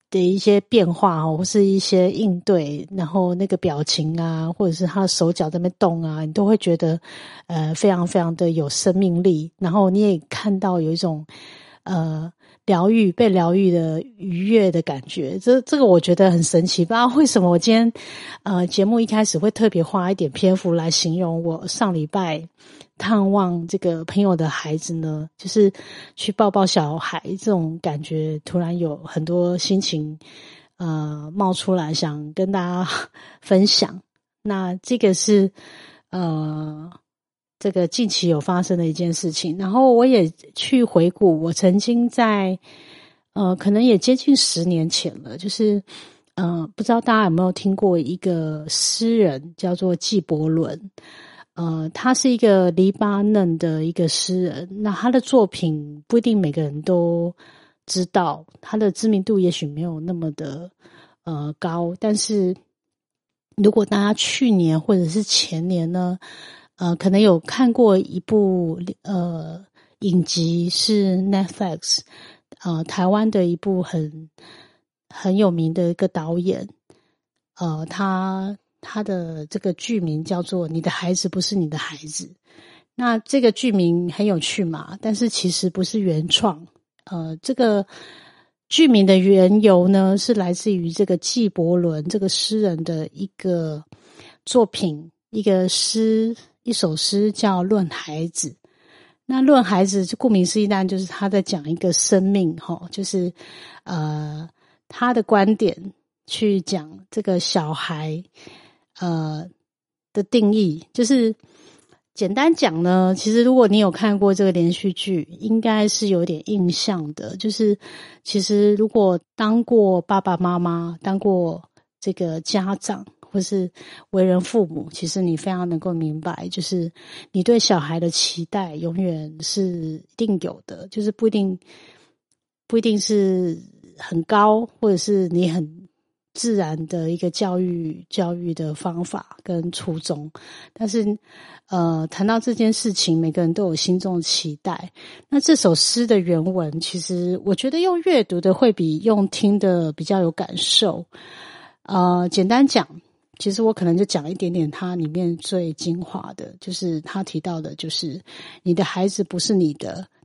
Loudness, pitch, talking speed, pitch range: -20 LUFS, 185 Hz, 220 characters per minute, 170-205 Hz